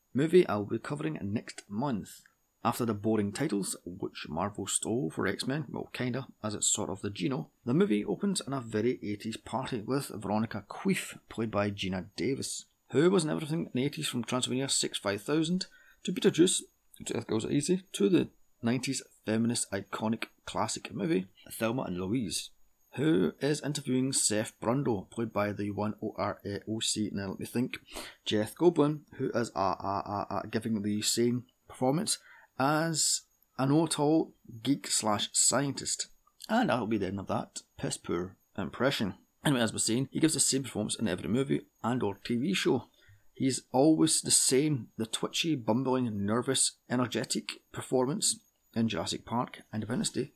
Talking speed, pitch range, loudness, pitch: 165 wpm, 105-135 Hz, -31 LUFS, 115 Hz